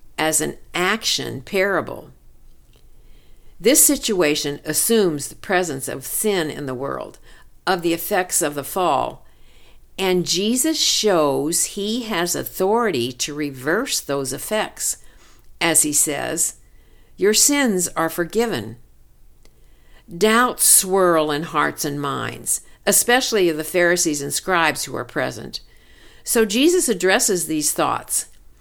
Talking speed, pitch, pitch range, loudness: 120 wpm, 175 Hz, 150-215 Hz, -19 LUFS